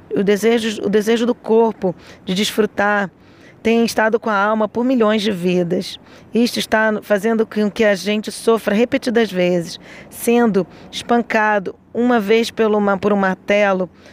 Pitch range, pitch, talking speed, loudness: 205-230 Hz, 215 Hz, 145 wpm, -17 LUFS